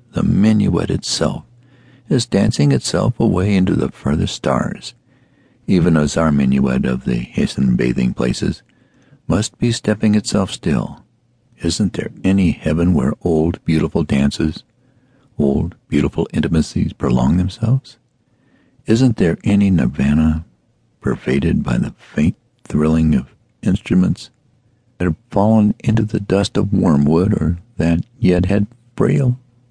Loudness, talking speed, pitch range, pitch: -17 LUFS, 125 wpm, 80-120 Hz, 100 Hz